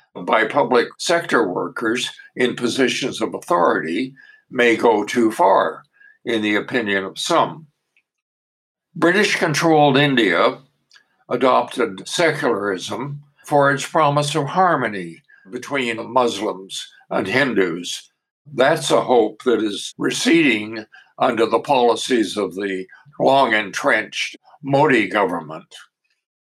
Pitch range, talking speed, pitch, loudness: 105-160 Hz, 105 wpm, 135 Hz, -18 LUFS